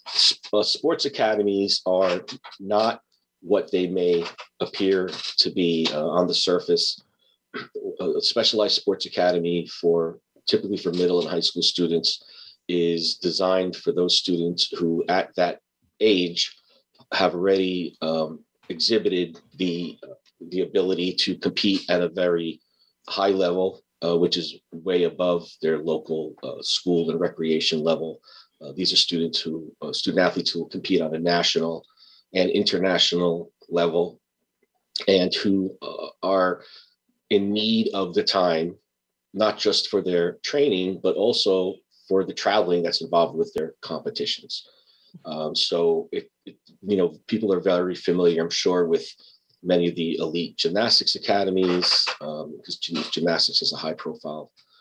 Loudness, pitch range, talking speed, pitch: -23 LUFS, 85-95 Hz, 140 wpm, 90 Hz